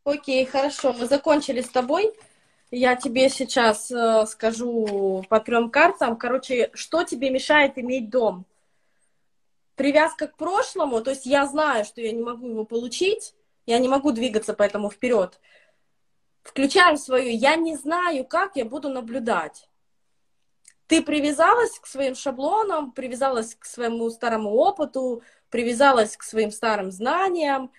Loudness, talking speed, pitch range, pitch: -22 LUFS, 135 wpm, 235-300 Hz, 260 Hz